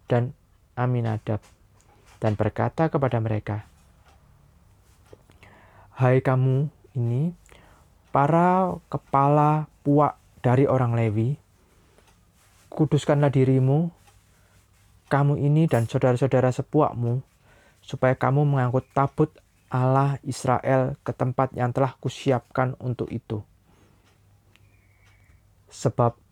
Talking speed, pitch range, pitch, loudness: 80 wpm, 100-135 Hz, 120 Hz, -24 LUFS